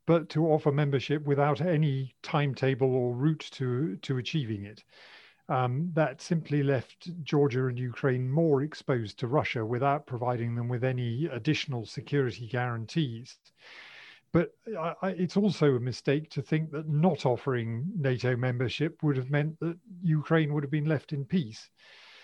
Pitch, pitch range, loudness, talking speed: 145 Hz, 125-155 Hz, -29 LUFS, 155 wpm